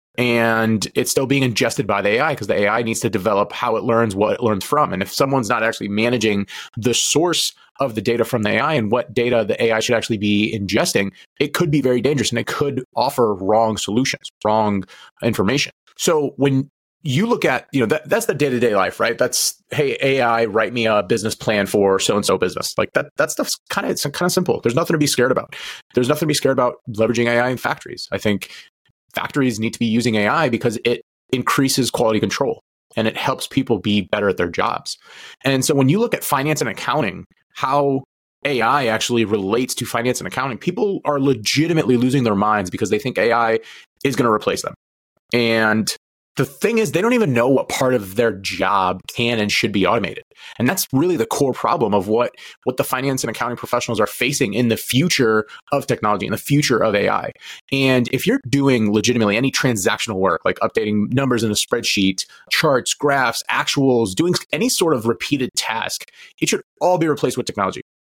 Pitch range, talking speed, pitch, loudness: 110-135 Hz, 210 wpm, 120 Hz, -19 LUFS